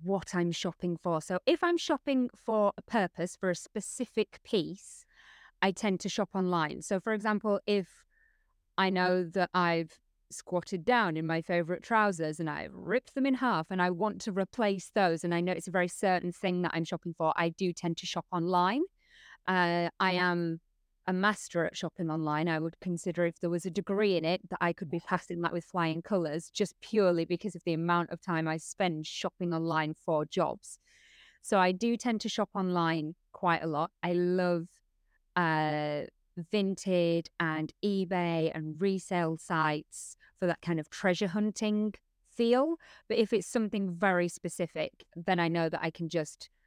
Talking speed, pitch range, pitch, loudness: 185 wpm, 170-200 Hz, 180 Hz, -31 LUFS